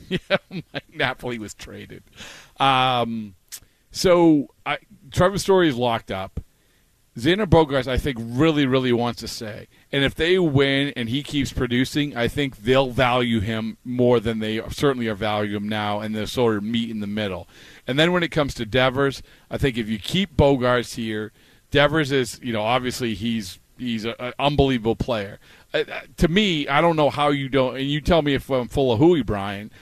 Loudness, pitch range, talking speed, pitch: -21 LUFS, 115-145 Hz, 190 wpm, 125 Hz